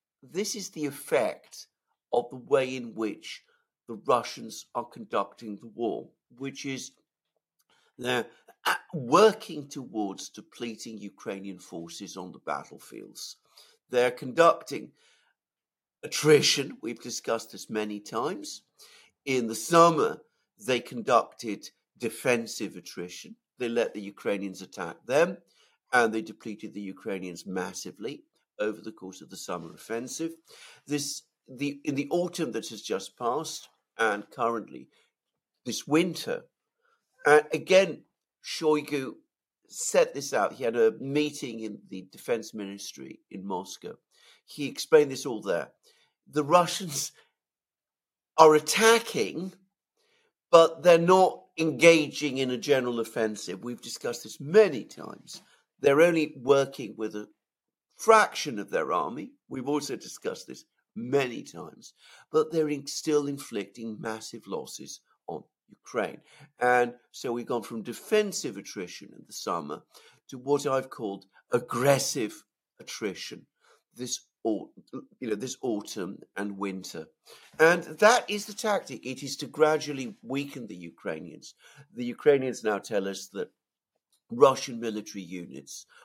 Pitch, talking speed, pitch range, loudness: 135 Hz, 125 wpm, 110-165 Hz, -27 LUFS